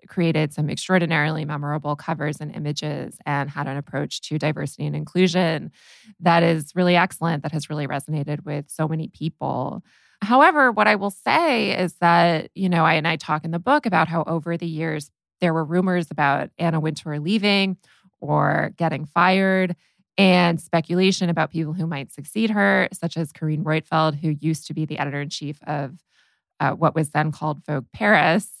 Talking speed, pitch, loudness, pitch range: 175 wpm, 160 Hz, -22 LUFS, 150-180 Hz